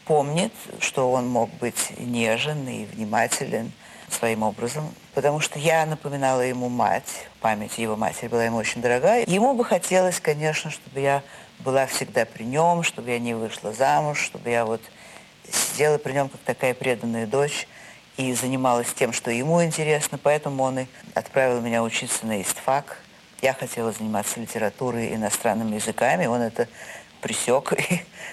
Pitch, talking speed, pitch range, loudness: 130 Hz, 150 wpm, 115-150 Hz, -24 LUFS